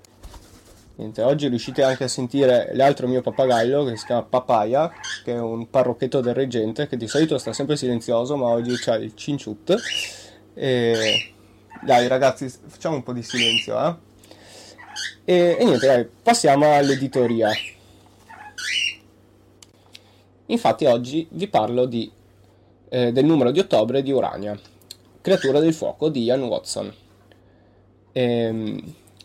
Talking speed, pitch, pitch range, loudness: 130 wpm, 120 Hz, 105-135 Hz, -21 LUFS